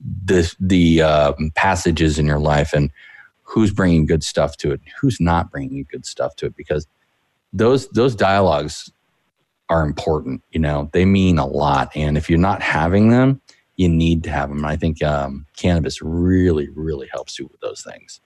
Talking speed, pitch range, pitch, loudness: 185 wpm, 75-95 Hz, 85 Hz, -18 LUFS